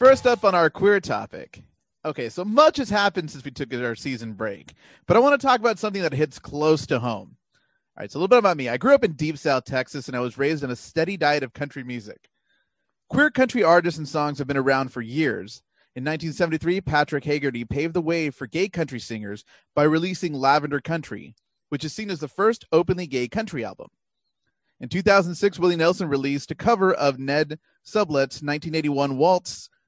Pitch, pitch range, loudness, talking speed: 155 Hz, 135-185 Hz, -22 LUFS, 205 wpm